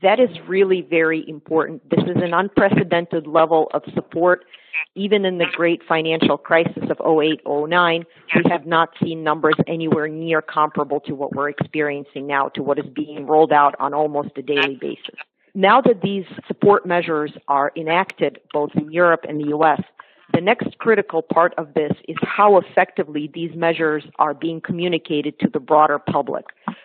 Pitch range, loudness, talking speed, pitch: 150-175 Hz, -19 LUFS, 170 wpm, 160 Hz